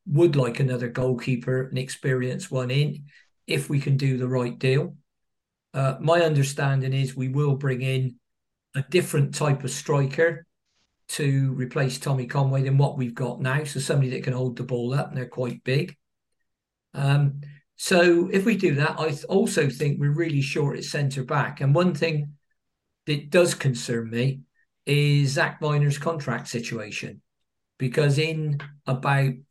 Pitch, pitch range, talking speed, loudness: 140 Hz, 130-155 Hz, 165 wpm, -24 LUFS